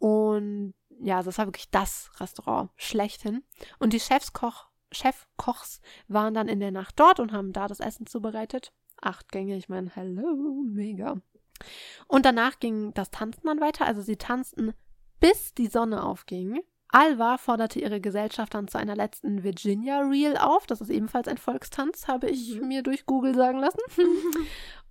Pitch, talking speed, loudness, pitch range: 230 Hz, 160 wpm, -27 LUFS, 205-275 Hz